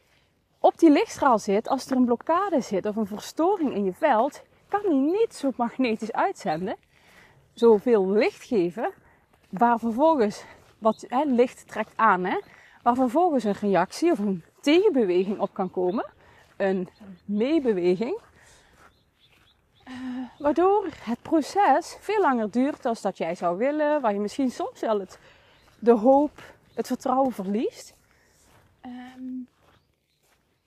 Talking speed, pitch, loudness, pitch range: 135 wpm, 250 Hz, -24 LUFS, 210-300 Hz